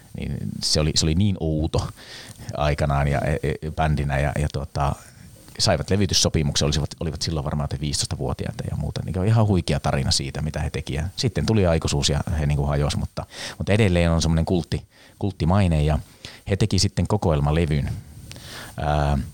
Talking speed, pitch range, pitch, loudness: 160 wpm, 75-95 Hz, 80 Hz, -23 LUFS